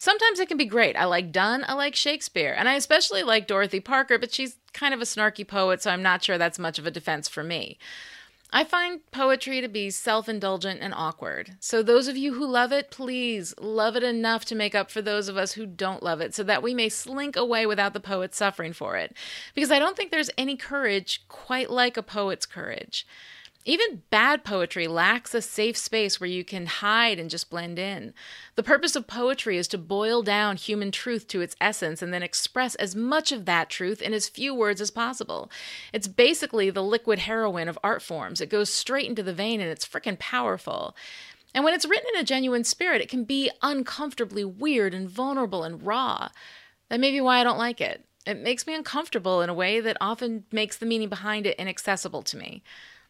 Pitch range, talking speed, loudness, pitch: 195-255 Hz, 215 wpm, -25 LUFS, 220 Hz